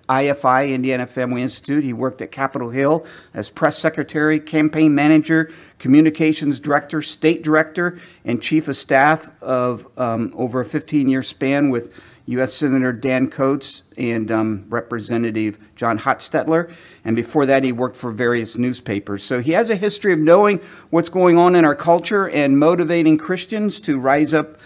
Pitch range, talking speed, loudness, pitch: 125-160 Hz, 160 wpm, -18 LUFS, 140 Hz